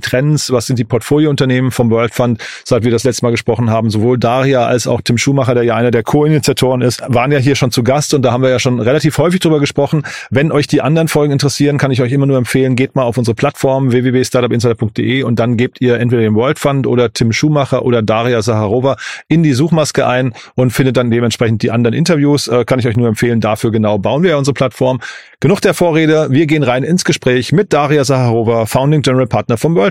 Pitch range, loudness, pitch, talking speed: 120-145 Hz, -12 LUFS, 130 Hz, 230 wpm